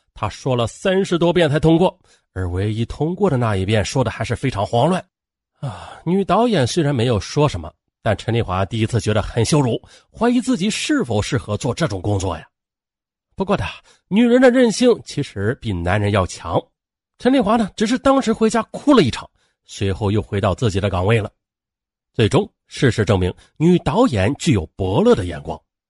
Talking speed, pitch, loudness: 280 characters per minute, 120 Hz, -18 LUFS